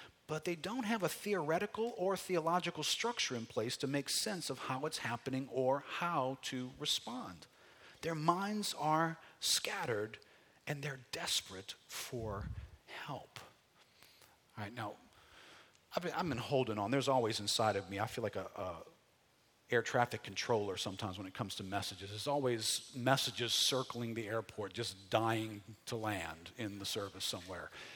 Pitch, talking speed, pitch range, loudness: 125 Hz, 155 wpm, 110-155 Hz, -38 LUFS